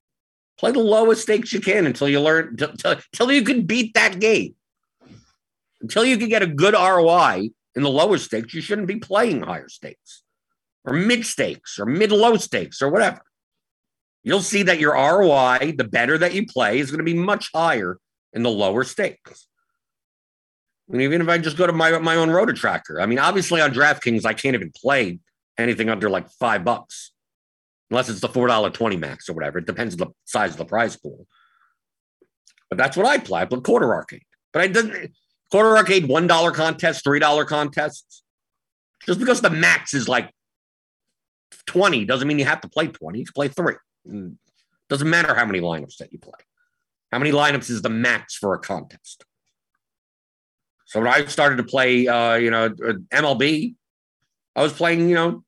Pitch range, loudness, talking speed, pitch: 125-200 Hz, -19 LUFS, 190 wpm, 160 Hz